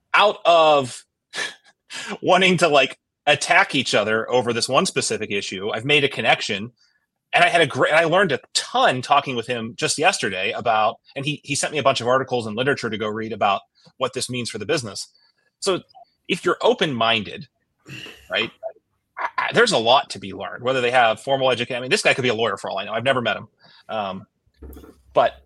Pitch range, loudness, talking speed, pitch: 120-150 Hz, -20 LUFS, 205 wpm, 135 Hz